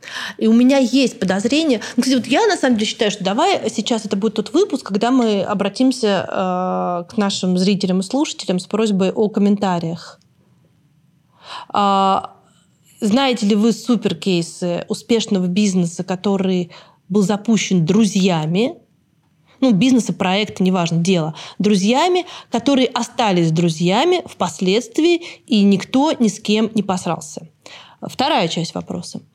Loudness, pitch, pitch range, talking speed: -17 LUFS, 205 Hz, 185-235 Hz, 125 wpm